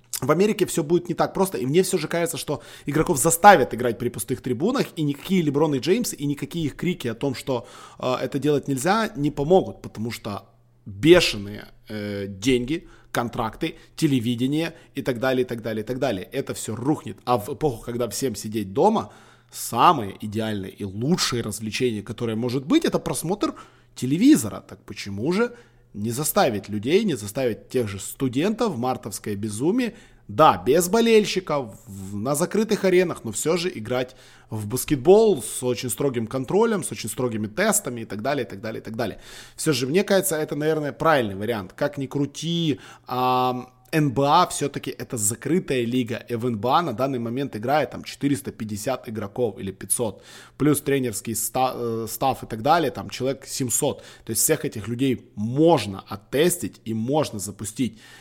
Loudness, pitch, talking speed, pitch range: -23 LUFS, 130 Hz, 170 wpm, 115-155 Hz